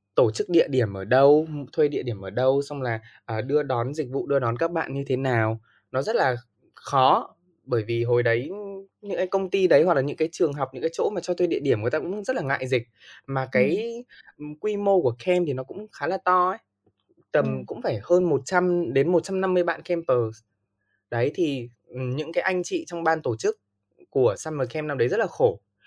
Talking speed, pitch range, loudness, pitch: 225 wpm, 125-180 Hz, -24 LUFS, 150 Hz